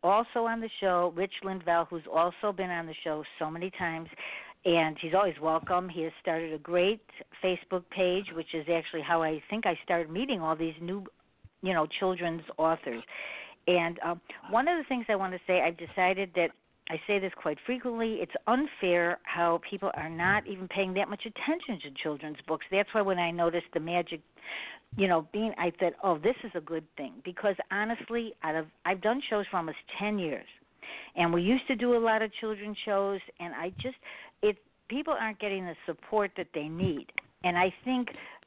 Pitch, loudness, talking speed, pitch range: 185 Hz, -31 LUFS, 200 wpm, 170-210 Hz